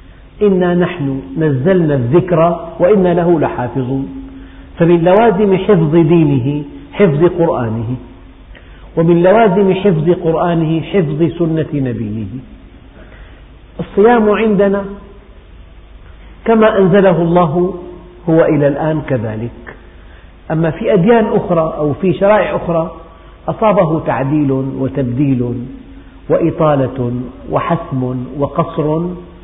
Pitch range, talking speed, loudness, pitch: 130-180 Hz, 90 wpm, -13 LUFS, 160 Hz